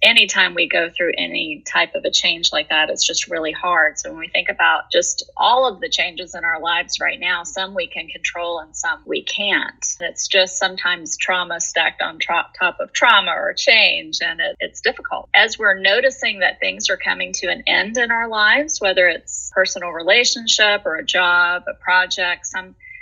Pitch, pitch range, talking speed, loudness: 190 Hz, 175-290 Hz, 200 wpm, -17 LUFS